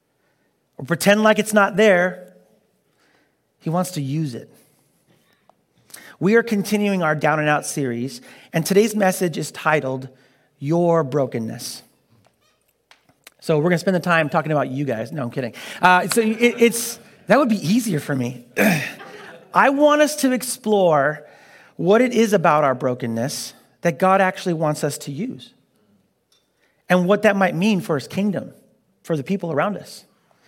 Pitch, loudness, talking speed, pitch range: 180 Hz, -19 LUFS, 155 wpm, 150-210 Hz